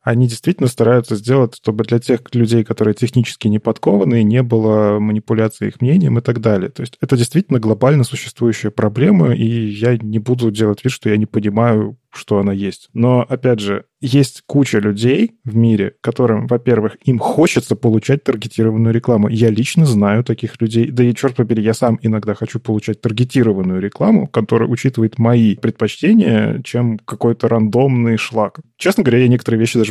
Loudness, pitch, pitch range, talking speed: -15 LUFS, 115 Hz, 110-125 Hz, 170 wpm